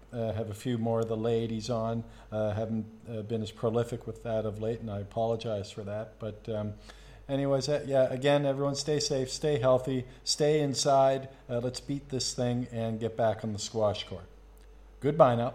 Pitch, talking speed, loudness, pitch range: 115 Hz, 195 wpm, -30 LUFS, 110-130 Hz